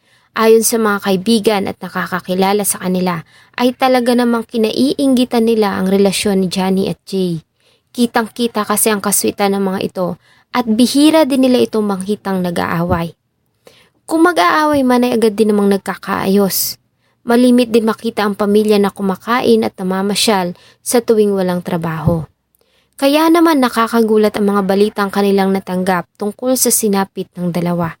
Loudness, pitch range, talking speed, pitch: -14 LUFS, 190-235 Hz, 145 wpm, 205 Hz